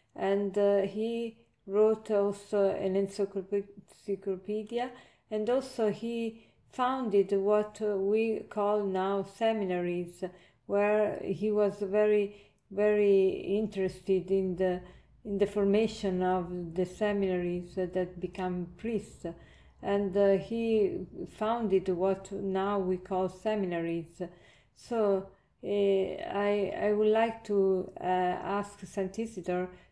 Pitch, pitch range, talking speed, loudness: 200 Hz, 185-210 Hz, 105 wpm, -31 LUFS